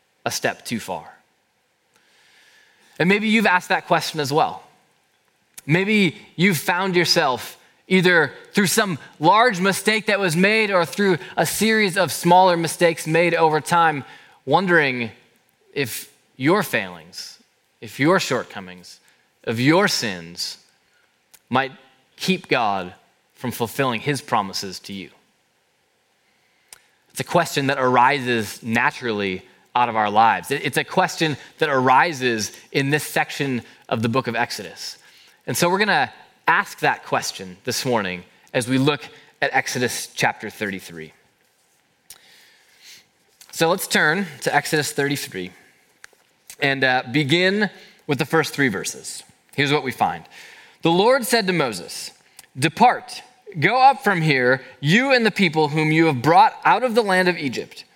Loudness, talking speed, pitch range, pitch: -20 LUFS, 140 wpm, 130-190 Hz, 155 Hz